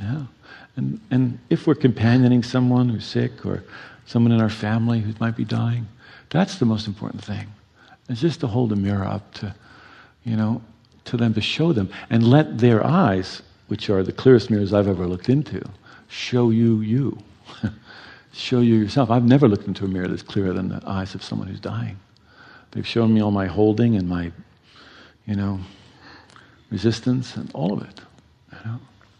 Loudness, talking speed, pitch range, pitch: -21 LUFS, 185 wpm, 100-125 Hz, 115 Hz